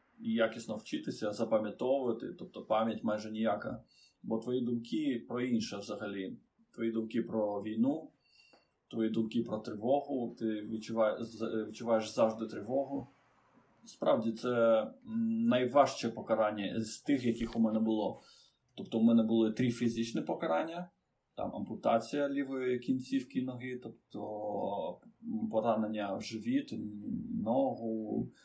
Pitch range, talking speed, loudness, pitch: 110-135 Hz, 110 wpm, -34 LUFS, 115 Hz